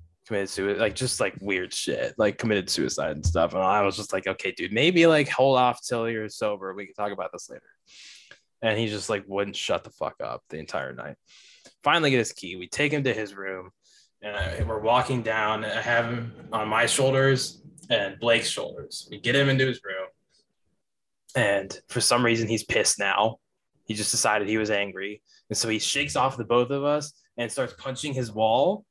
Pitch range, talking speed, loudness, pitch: 105-135 Hz, 210 wpm, -25 LUFS, 115 Hz